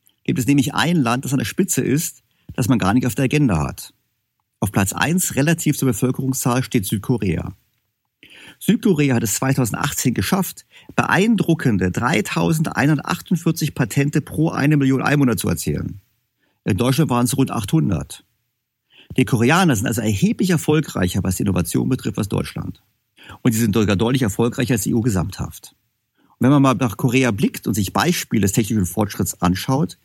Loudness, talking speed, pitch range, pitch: -19 LUFS, 165 wpm, 115-145 Hz, 130 Hz